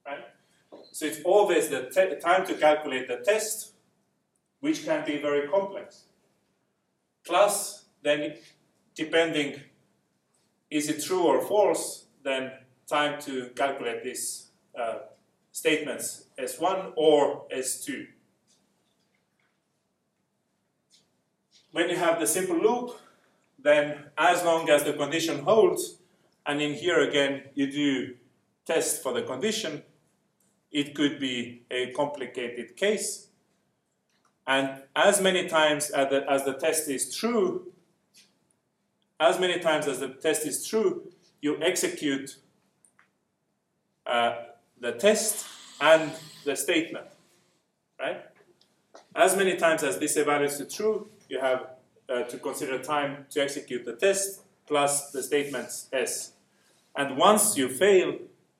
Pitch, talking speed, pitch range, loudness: 155 Hz, 120 wpm, 140-200 Hz, -26 LUFS